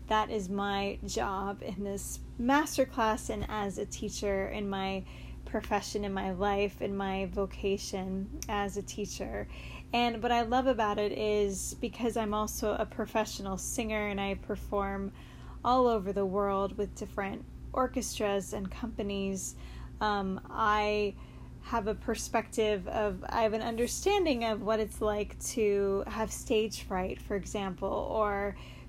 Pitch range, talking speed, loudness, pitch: 200-220 Hz, 145 wpm, -32 LUFS, 210 Hz